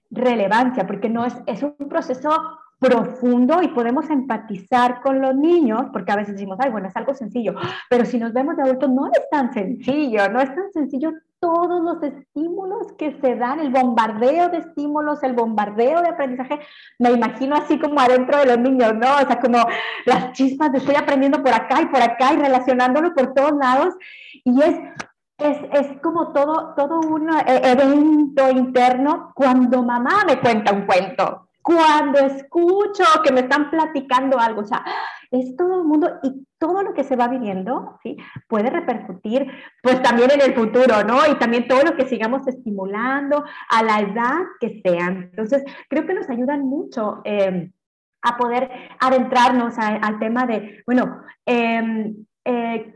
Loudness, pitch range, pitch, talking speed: -19 LUFS, 240-295 Hz, 260 Hz, 170 wpm